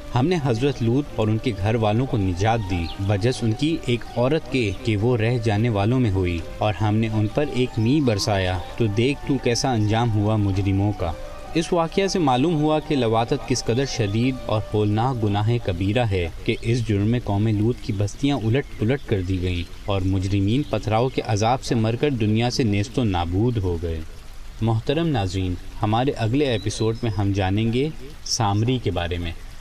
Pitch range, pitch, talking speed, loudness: 100-125 Hz, 110 Hz, 195 wpm, -22 LUFS